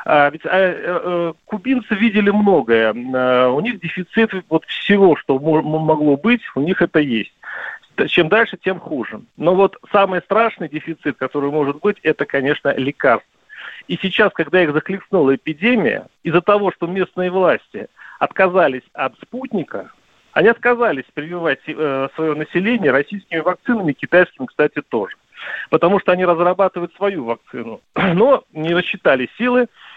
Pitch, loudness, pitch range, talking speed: 175 Hz, -17 LUFS, 150-200 Hz, 140 wpm